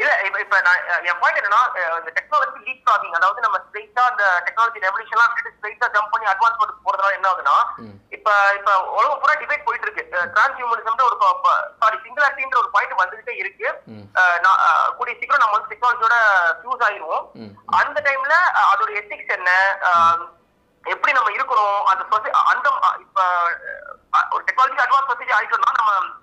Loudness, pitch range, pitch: -18 LUFS, 195-260 Hz, 220 Hz